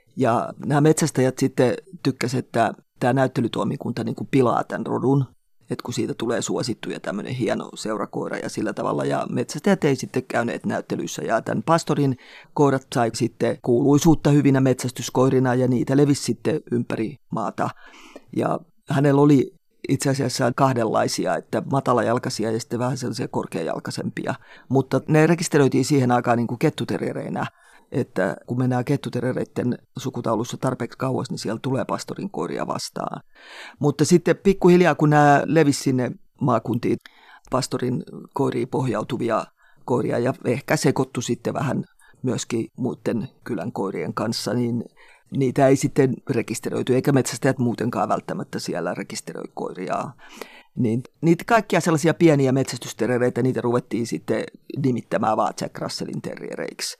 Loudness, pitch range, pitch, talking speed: -22 LUFS, 120-145 Hz, 130 Hz, 130 wpm